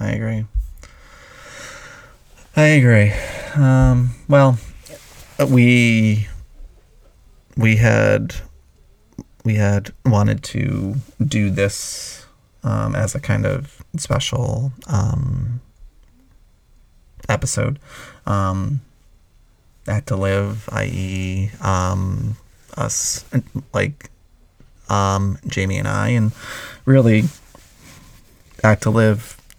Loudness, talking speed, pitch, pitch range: -18 LUFS, 80 wpm, 110 Hz, 100-130 Hz